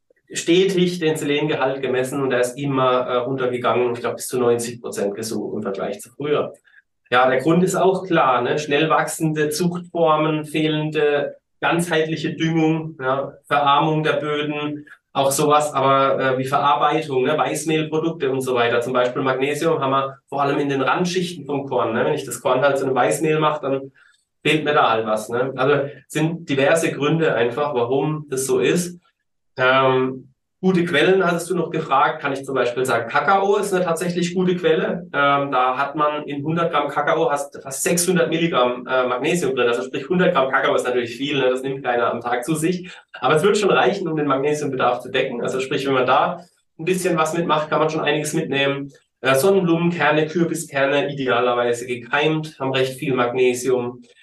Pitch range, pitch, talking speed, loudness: 130-160 Hz, 145 Hz, 185 wpm, -20 LUFS